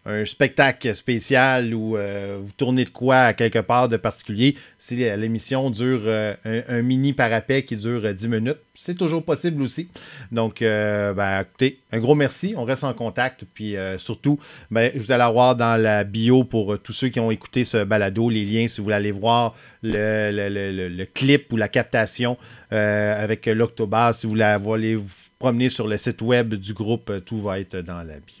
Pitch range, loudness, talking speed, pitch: 105-125 Hz, -21 LUFS, 205 wpm, 115 Hz